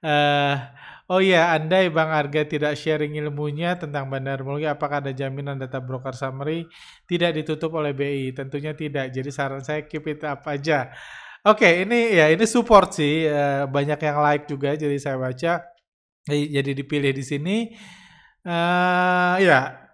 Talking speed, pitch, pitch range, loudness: 165 wpm, 150 Hz, 140-170 Hz, -22 LUFS